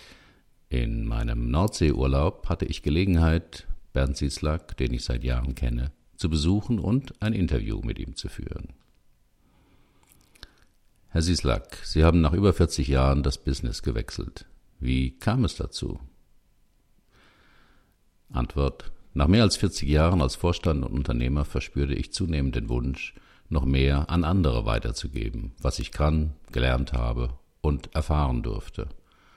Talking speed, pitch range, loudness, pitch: 135 wpm, 65-90 Hz, -26 LUFS, 75 Hz